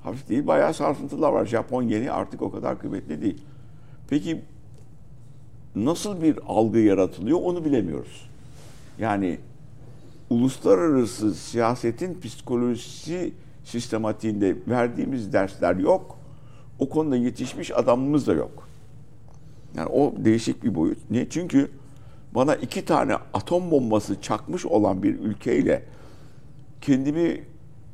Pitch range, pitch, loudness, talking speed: 120-140 Hz, 130 Hz, -24 LUFS, 105 wpm